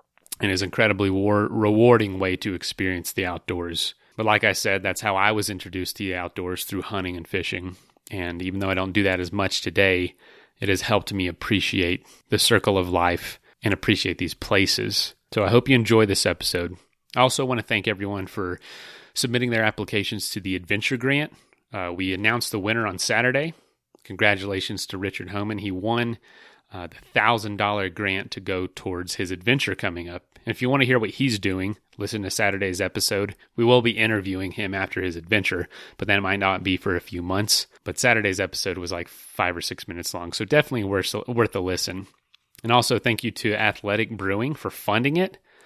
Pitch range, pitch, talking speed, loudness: 95-115 Hz, 100 Hz, 200 wpm, -23 LUFS